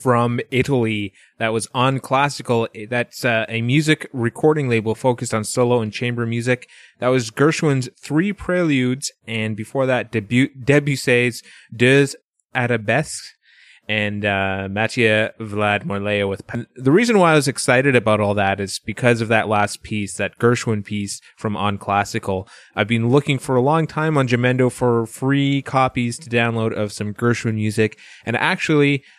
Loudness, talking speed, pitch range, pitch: -19 LUFS, 160 wpm, 110-135 Hz, 120 Hz